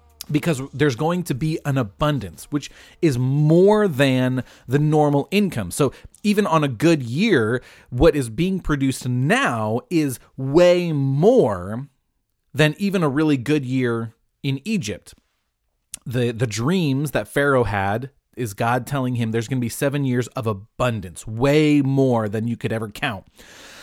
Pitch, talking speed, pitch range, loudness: 135 Hz, 155 wpm, 120-150 Hz, -20 LUFS